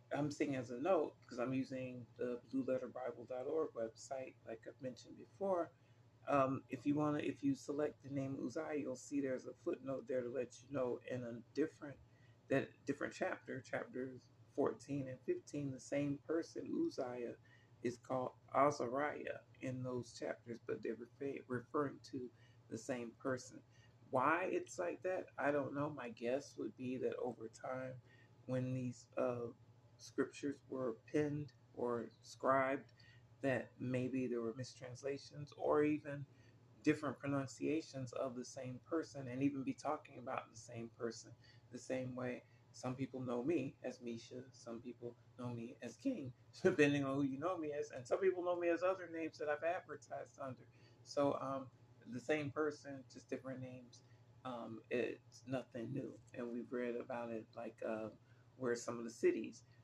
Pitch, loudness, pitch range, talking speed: 125 Hz, -43 LUFS, 120-140 Hz, 165 wpm